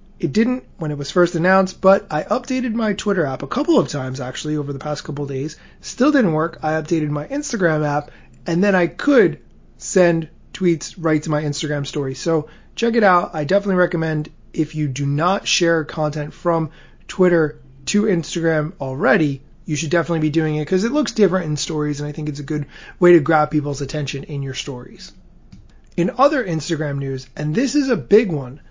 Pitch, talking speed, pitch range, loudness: 160 Hz, 205 wpm, 150-185 Hz, -19 LUFS